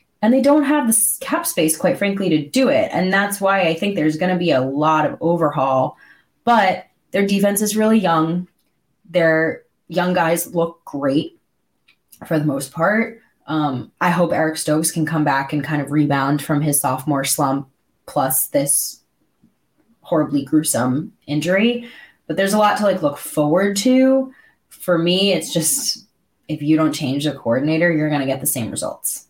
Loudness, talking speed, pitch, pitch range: -18 LUFS, 180 wpm, 165 Hz, 150-200 Hz